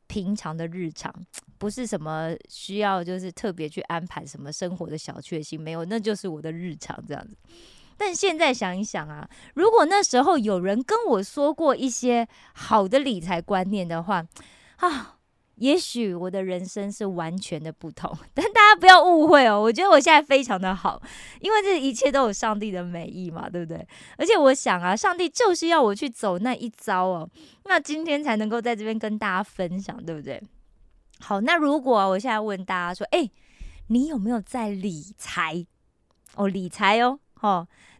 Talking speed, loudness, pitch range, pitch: 275 characters per minute, -22 LUFS, 180-265 Hz, 205 Hz